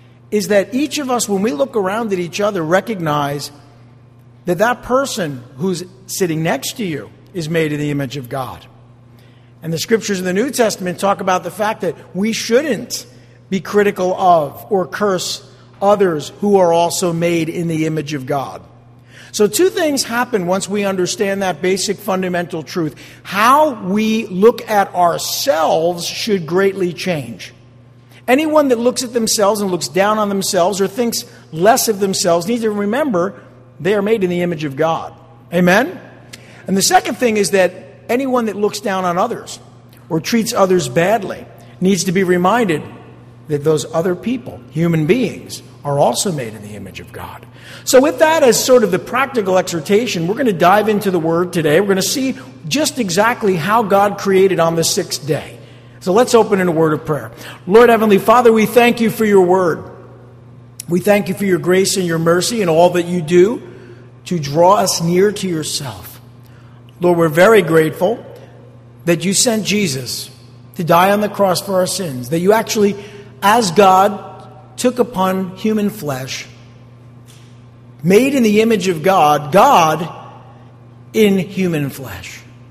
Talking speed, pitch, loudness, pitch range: 175 wpm, 180 Hz, -15 LUFS, 145-205 Hz